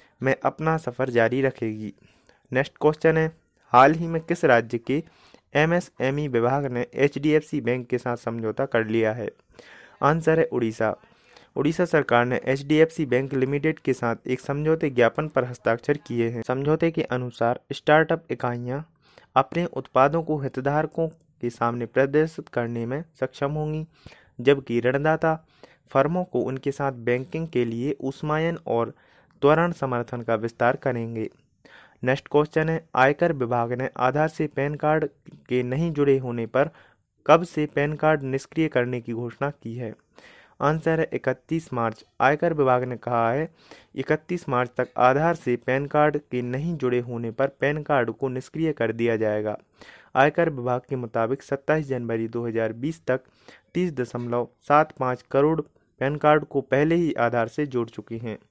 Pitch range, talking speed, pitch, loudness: 120-155 Hz, 165 wpm, 135 Hz, -24 LUFS